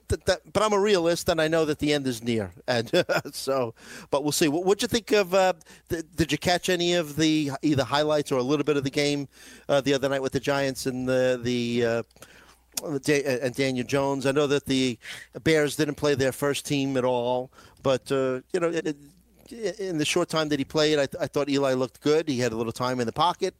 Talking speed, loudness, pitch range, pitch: 235 wpm, -25 LUFS, 130-160 Hz, 145 Hz